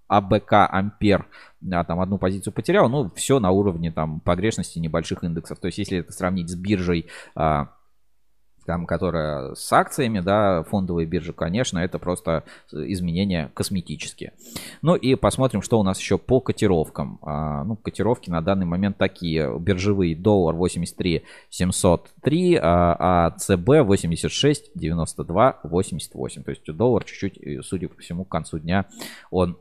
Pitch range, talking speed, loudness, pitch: 85-100 Hz, 145 wpm, -22 LUFS, 90 Hz